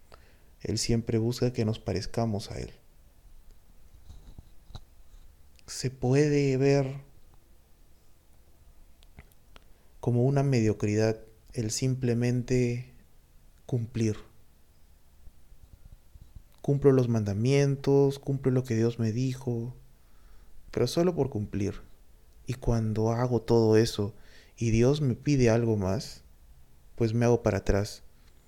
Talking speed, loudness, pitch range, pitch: 95 wpm, -28 LUFS, 75-120 Hz, 110 Hz